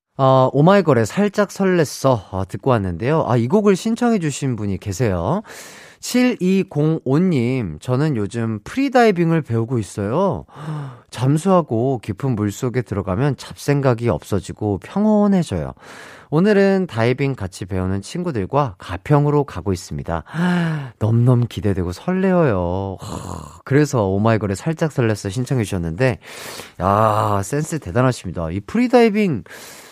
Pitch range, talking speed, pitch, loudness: 100-160 Hz, 290 characters per minute, 130 Hz, -19 LUFS